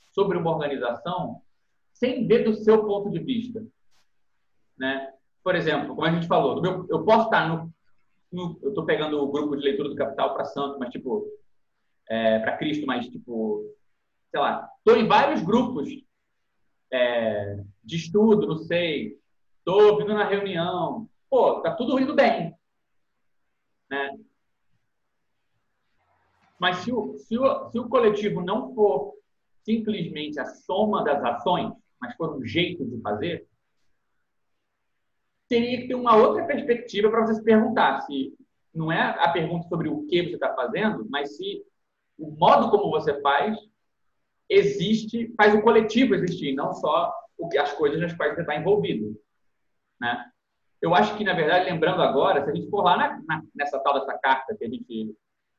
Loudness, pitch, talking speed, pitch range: -24 LUFS, 190 Hz, 160 wpm, 140-225 Hz